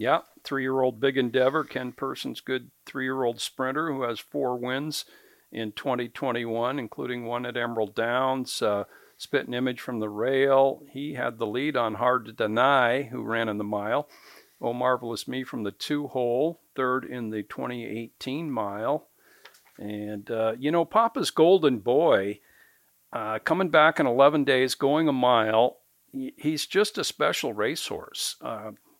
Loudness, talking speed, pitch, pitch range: -26 LUFS, 150 wpm, 130 Hz, 115-135 Hz